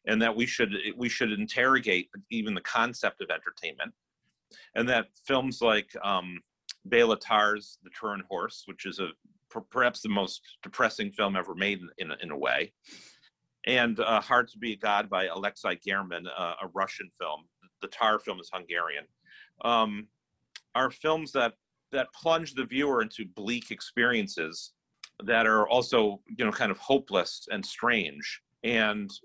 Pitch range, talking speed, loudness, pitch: 100-125 Hz, 160 wpm, -29 LUFS, 110 Hz